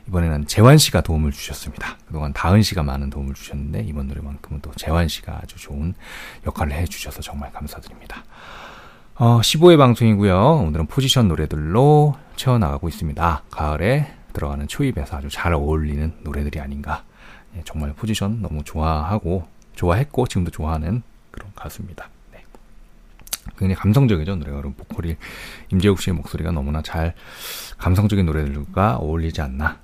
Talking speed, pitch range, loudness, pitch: 370 characters per minute, 75-105 Hz, -20 LUFS, 80 Hz